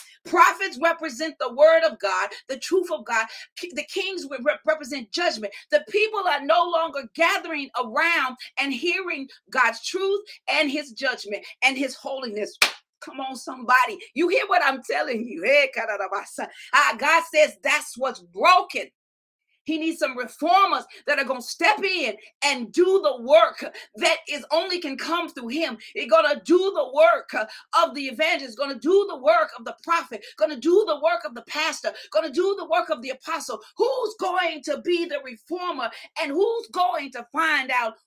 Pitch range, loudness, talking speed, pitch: 270-345 Hz, -23 LUFS, 180 wpm, 315 Hz